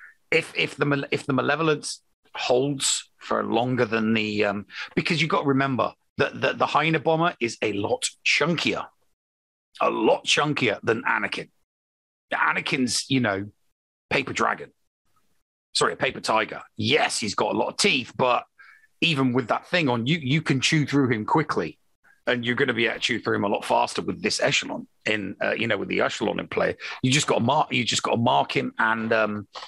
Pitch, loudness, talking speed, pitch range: 125 Hz, -24 LUFS, 190 wpm, 110-145 Hz